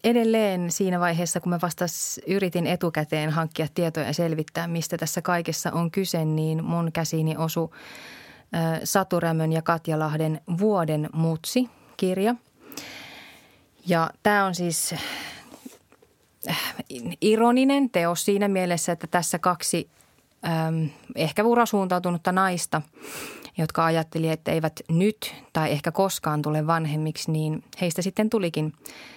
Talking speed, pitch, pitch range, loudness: 115 wpm, 170 Hz, 160-190 Hz, -25 LUFS